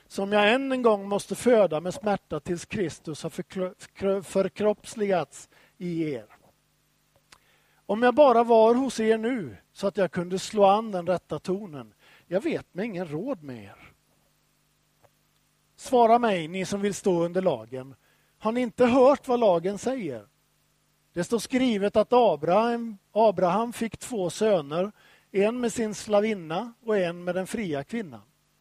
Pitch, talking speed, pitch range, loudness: 200 Hz, 150 wpm, 180-230 Hz, -25 LUFS